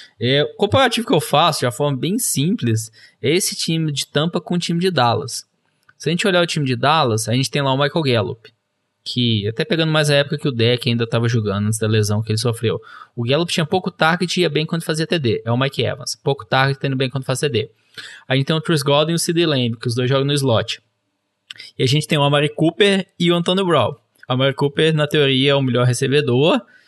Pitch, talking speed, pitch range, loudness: 140 Hz, 250 wpm, 125-160 Hz, -18 LUFS